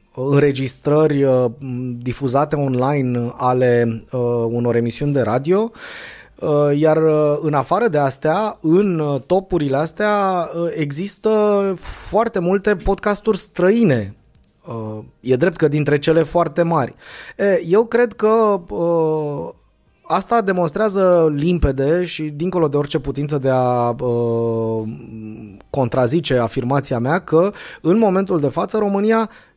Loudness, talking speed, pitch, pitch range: -18 LUFS, 120 wpm, 155 Hz, 130-185 Hz